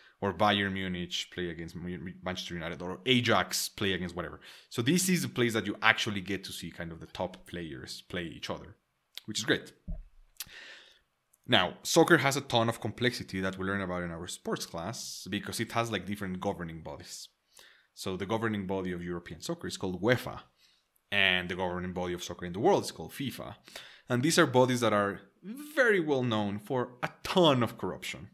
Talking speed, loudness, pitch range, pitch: 195 wpm, -31 LUFS, 90-115 Hz, 100 Hz